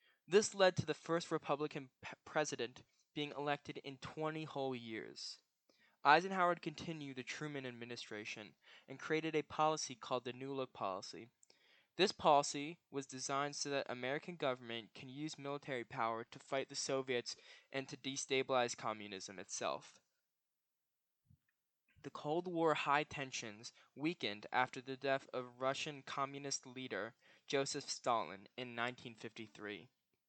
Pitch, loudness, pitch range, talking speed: 135 Hz, -40 LUFS, 125-150 Hz, 130 wpm